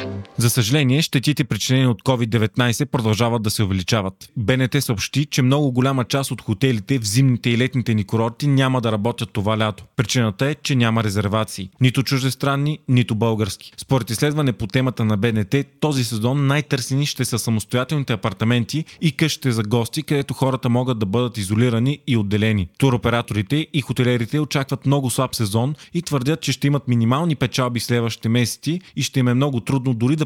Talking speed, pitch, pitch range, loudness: 175 wpm, 125 Hz, 115-140 Hz, -20 LUFS